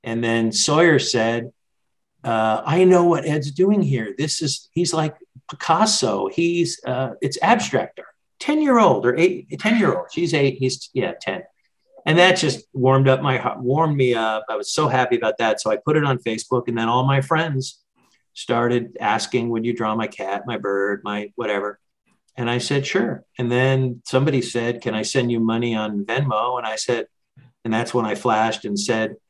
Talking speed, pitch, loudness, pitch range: 200 wpm, 130 Hz, -20 LUFS, 115-155 Hz